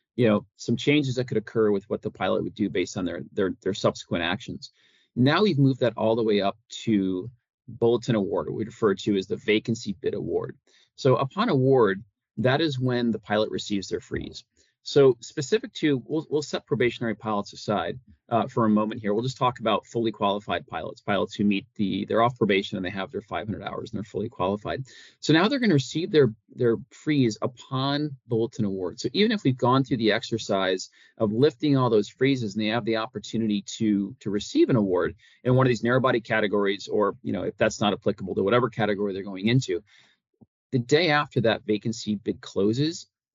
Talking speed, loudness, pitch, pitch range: 210 wpm, -25 LUFS, 115 Hz, 105-130 Hz